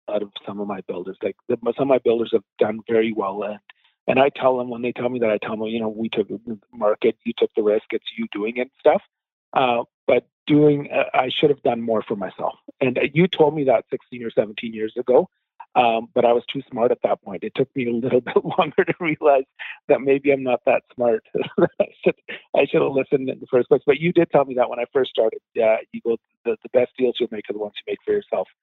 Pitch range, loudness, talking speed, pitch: 115-155 Hz, -21 LUFS, 265 wpm, 125 Hz